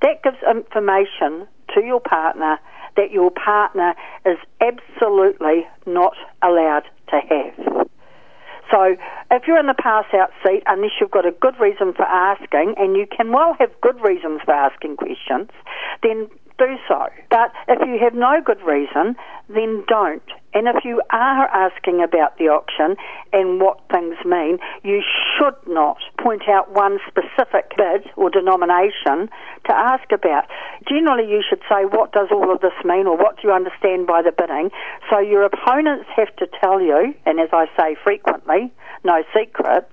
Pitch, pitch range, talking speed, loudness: 205 Hz, 185-260 Hz, 165 wpm, -18 LUFS